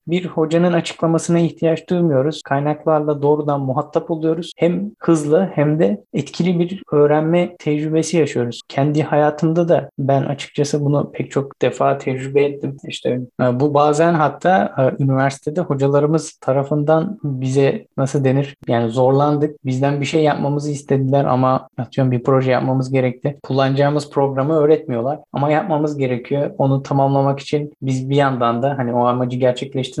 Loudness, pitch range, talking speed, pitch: -18 LUFS, 135-160 Hz, 140 wpm, 145 Hz